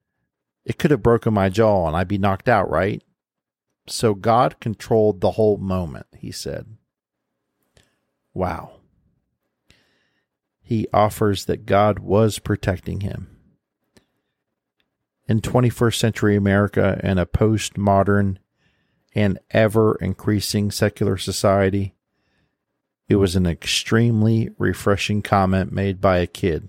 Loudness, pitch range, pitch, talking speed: -20 LUFS, 95-110 Hz, 100 Hz, 110 wpm